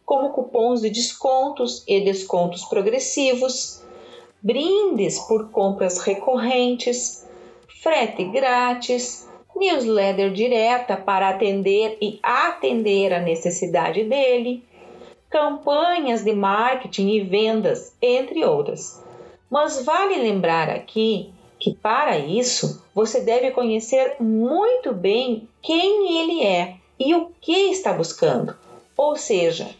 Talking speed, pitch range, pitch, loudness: 105 wpm, 210-315 Hz, 245 Hz, -21 LUFS